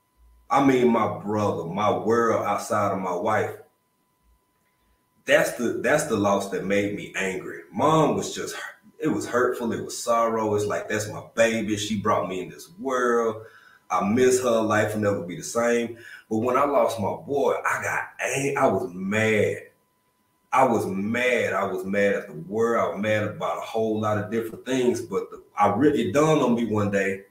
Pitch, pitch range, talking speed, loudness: 110 Hz, 100-115 Hz, 190 wpm, -24 LUFS